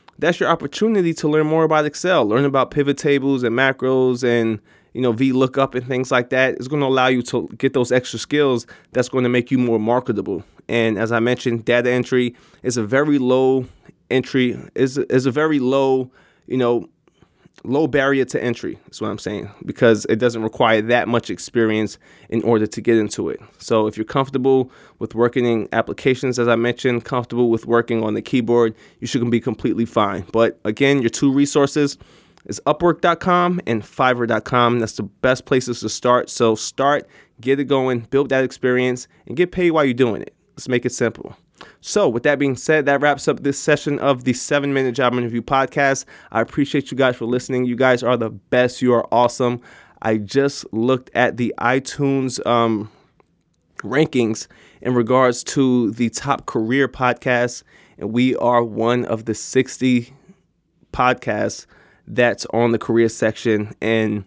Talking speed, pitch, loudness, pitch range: 180 wpm, 125 Hz, -19 LUFS, 115-135 Hz